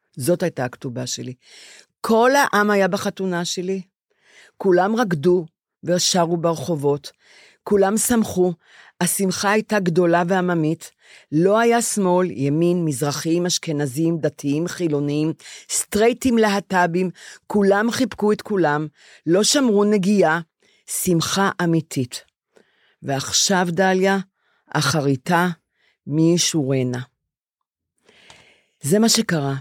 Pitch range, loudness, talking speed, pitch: 155-200 Hz, -20 LUFS, 95 wpm, 175 Hz